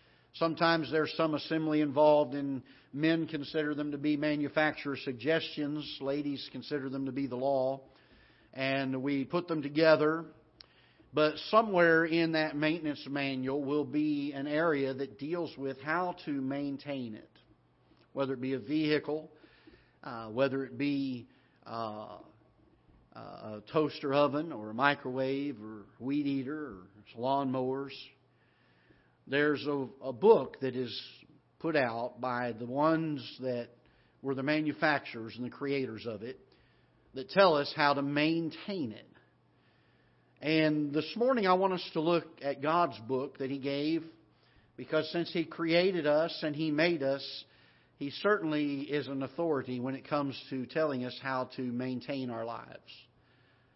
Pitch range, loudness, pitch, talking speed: 130-155 Hz, -32 LUFS, 140 Hz, 145 wpm